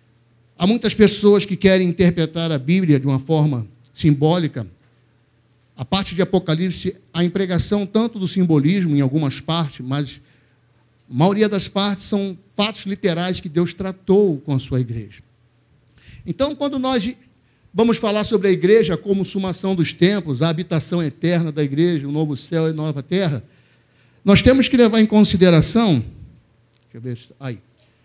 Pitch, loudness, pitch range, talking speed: 165 Hz, -18 LUFS, 135-195 Hz, 155 wpm